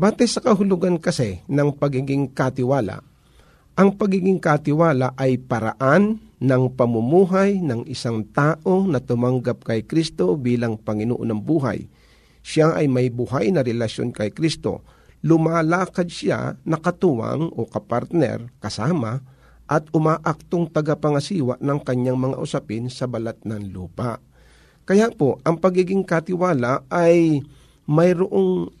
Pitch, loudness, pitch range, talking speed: 145 Hz, -21 LUFS, 125-175 Hz, 120 wpm